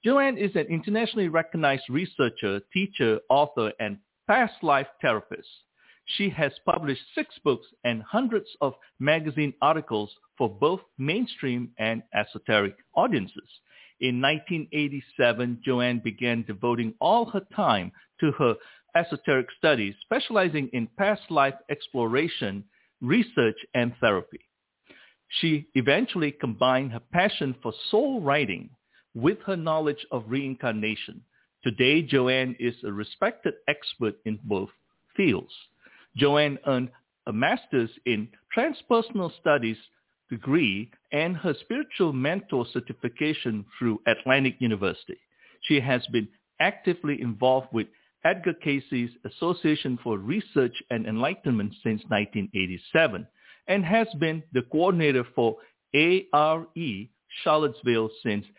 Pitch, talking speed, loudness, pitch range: 135 Hz, 115 wpm, -26 LUFS, 120-165 Hz